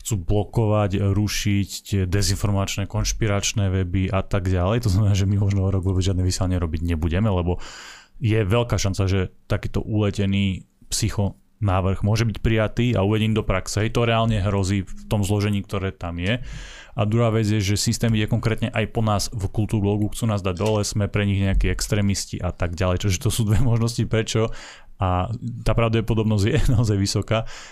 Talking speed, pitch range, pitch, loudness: 180 wpm, 95-110 Hz, 105 Hz, -22 LUFS